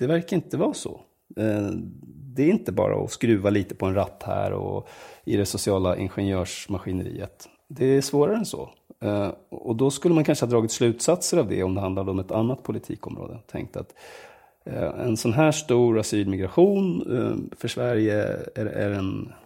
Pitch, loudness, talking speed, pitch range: 110 Hz, -24 LUFS, 165 wpm, 100-135 Hz